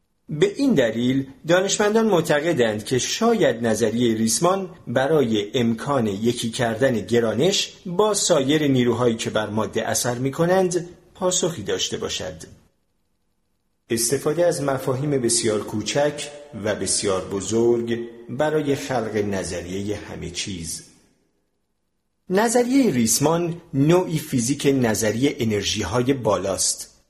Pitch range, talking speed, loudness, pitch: 110-165 Hz, 105 wpm, -21 LUFS, 130 Hz